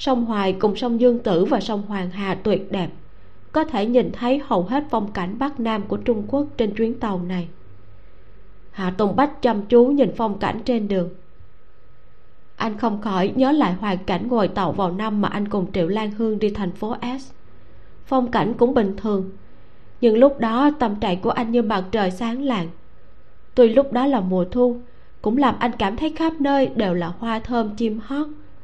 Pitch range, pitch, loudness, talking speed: 190-245 Hz, 220 Hz, -21 LUFS, 200 wpm